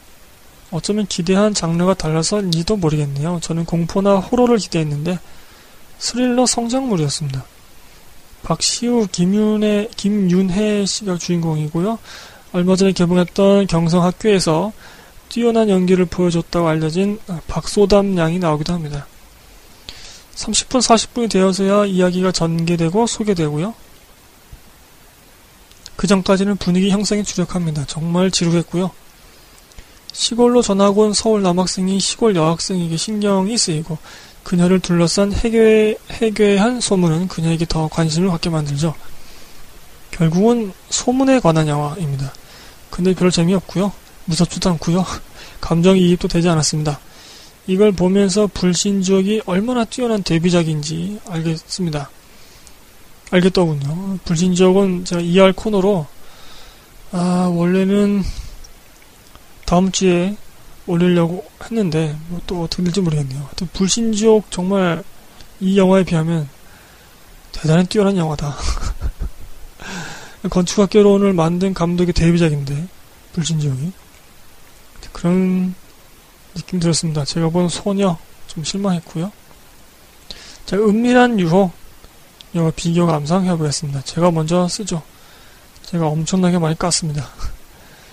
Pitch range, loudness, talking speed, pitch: 165-200 Hz, -17 LUFS, 275 characters per minute, 180 Hz